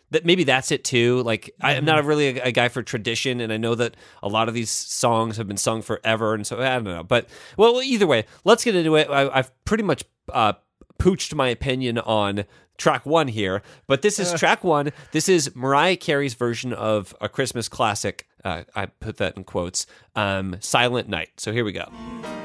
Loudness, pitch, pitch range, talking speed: -22 LUFS, 125 Hz, 110-150 Hz, 210 wpm